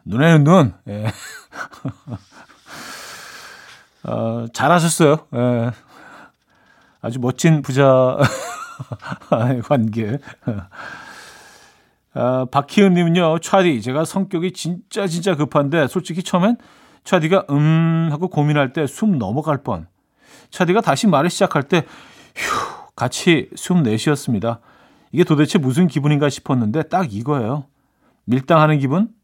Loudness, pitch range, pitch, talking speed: -18 LUFS, 130-175 Hz, 150 Hz, 215 characters per minute